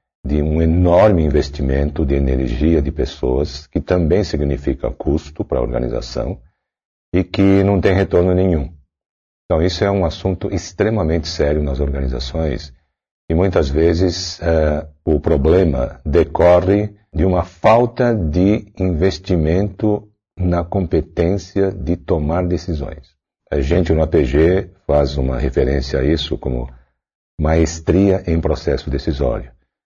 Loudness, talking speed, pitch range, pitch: -17 LUFS, 125 wpm, 75-95 Hz, 85 Hz